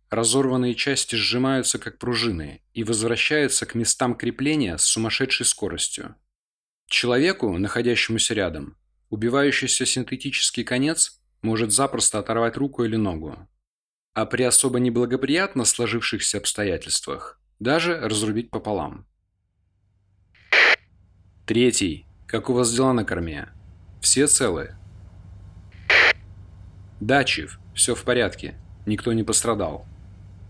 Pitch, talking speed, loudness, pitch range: 115 Hz, 100 wpm, -21 LUFS, 95-125 Hz